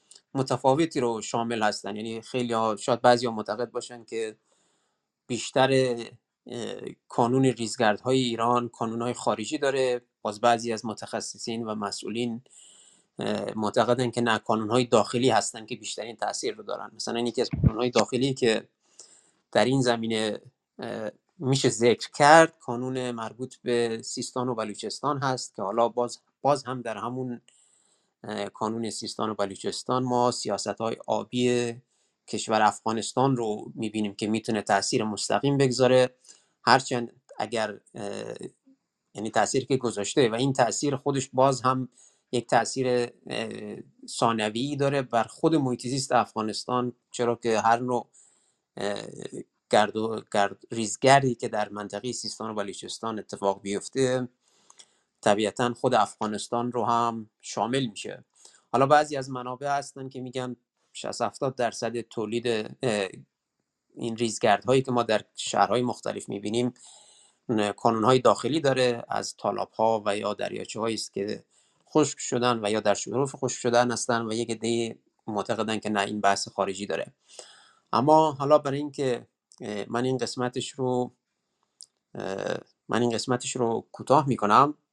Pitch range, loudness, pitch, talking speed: 110-130 Hz, -27 LUFS, 120 Hz, 135 wpm